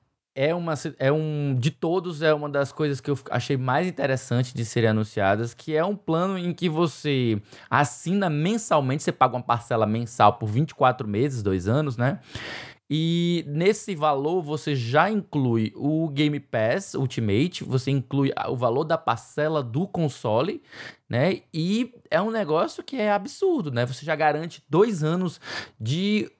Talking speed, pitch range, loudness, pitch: 160 wpm, 130-170 Hz, -25 LUFS, 150 Hz